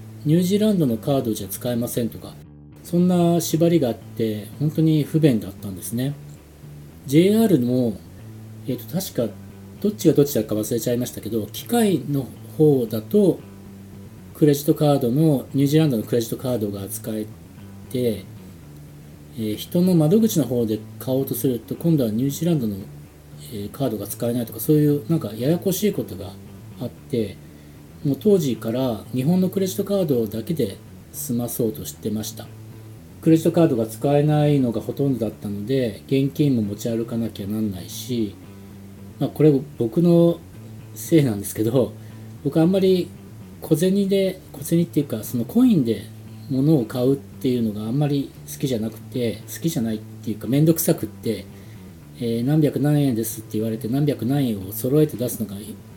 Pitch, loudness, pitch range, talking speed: 120 Hz, -22 LUFS, 110-150 Hz, 355 characters per minute